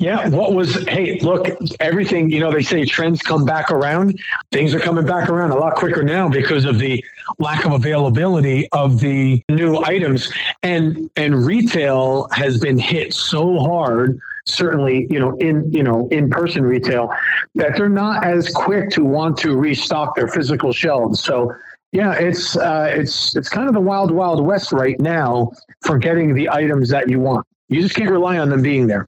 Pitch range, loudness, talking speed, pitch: 135-175 Hz, -17 LUFS, 185 wpm, 155 Hz